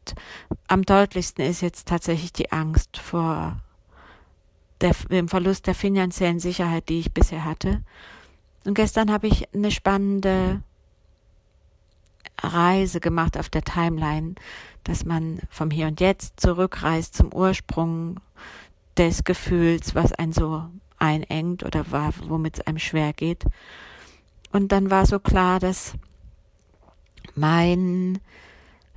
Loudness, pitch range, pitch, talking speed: -23 LUFS, 140-185 Hz, 165 Hz, 115 wpm